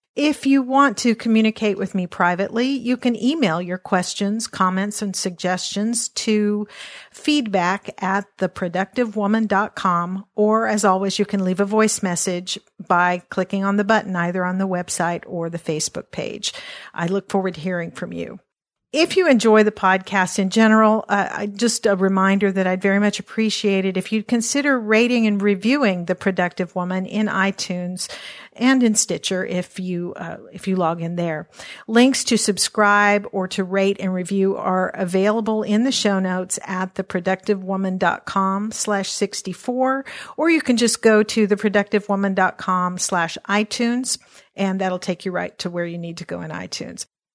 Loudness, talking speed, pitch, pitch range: -20 LUFS, 160 wpm, 200 Hz, 185-220 Hz